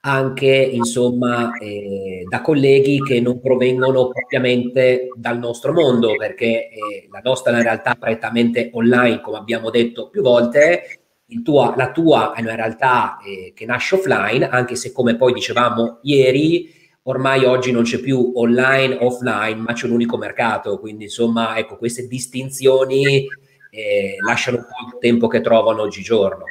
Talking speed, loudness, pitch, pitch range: 155 wpm, -17 LUFS, 125 Hz, 115-130 Hz